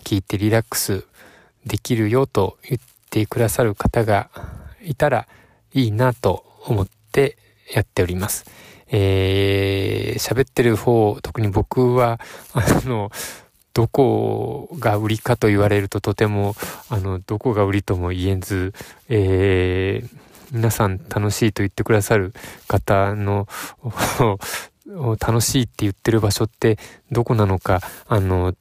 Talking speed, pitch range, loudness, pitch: 245 characters per minute, 100-115 Hz, -20 LUFS, 105 Hz